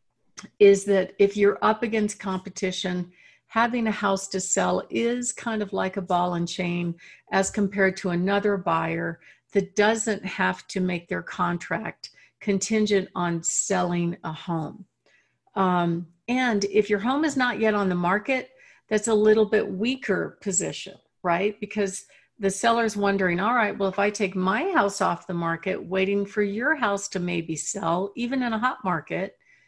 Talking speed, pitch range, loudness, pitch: 165 wpm, 180-215 Hz, -25 LUFS, 200 Hz